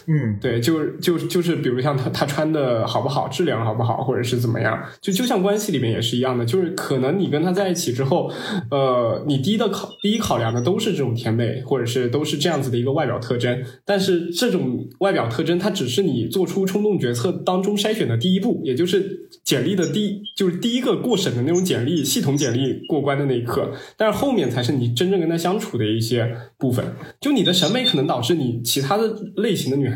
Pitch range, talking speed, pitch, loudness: 125-195 Hz, 355 characters per minute, 155 Hz, -21 LUFS